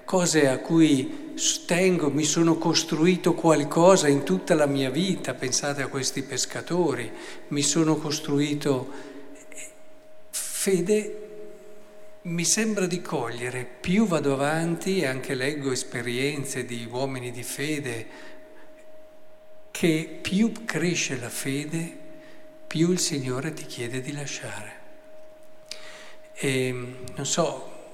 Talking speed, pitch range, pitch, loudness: 110 wpm, 140-210 Hz, 165 Hz, -25 LUFS